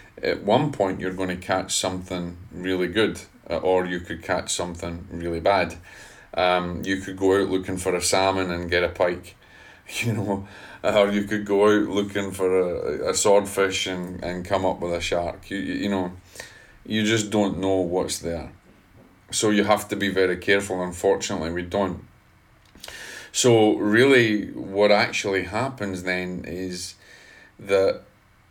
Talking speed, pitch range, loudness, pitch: 160 wpm, 90-100 Hz, -23 LUFS, 95 Hz